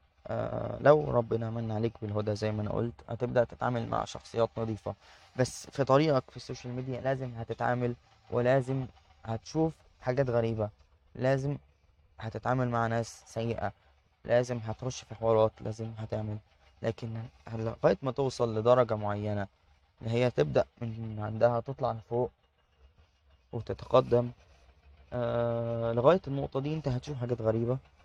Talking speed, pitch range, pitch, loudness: 125 wpm, 105-125 Hz, 115 Hz, -31 LUFS